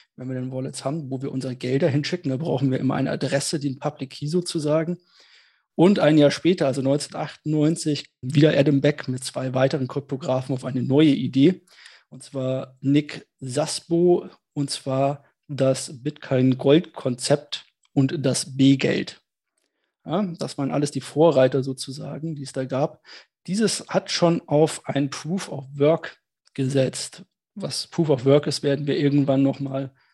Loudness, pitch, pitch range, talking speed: -23 LUFS, 140 Hz, 135-155 Hz, 145 wpm